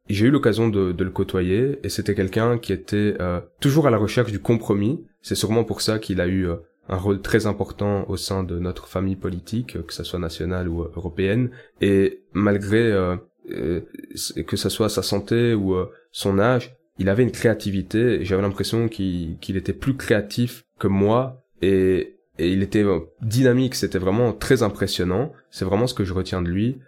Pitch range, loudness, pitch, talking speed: 95-115 Hz, -22 LUFS, 100 Hz, 195 wpm